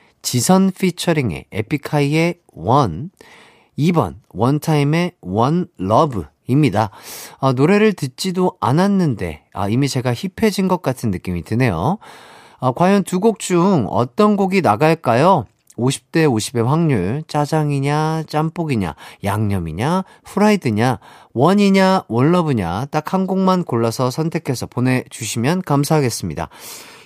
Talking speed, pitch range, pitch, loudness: 255 characters per minute, 115-180 Hz, 145 Hz, -18 LUFS